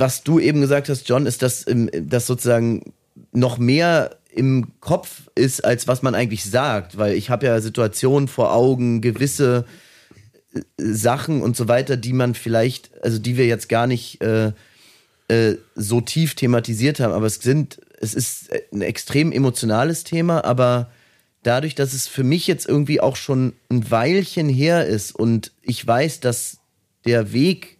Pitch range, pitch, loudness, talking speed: 115-140 Hz, 125 Hz, -19 LUFS, 165 wpm